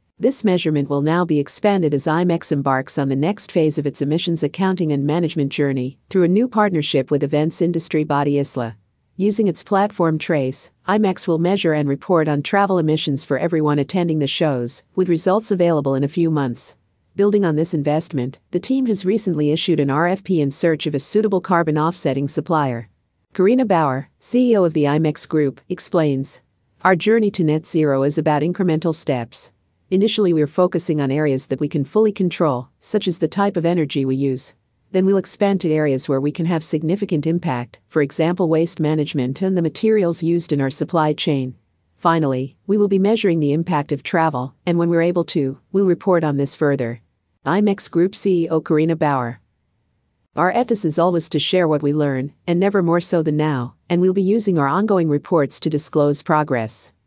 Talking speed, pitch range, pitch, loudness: 190 wpm, 145-180 Hz, 160 Hz, -19 LUFS